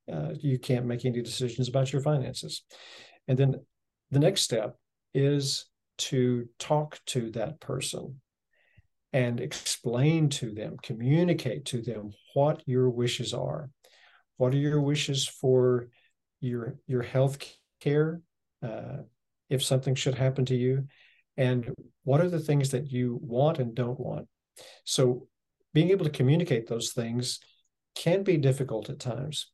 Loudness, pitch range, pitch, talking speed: -29 LUFS, 125-145 Hz, 130 Hz, 140 wpm